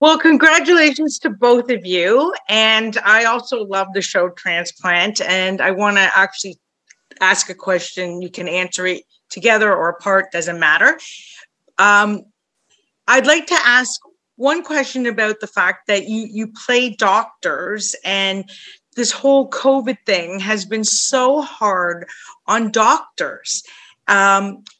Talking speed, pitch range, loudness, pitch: 140 wpm, 190-255 Hz, -15 LUFS, 210 Hz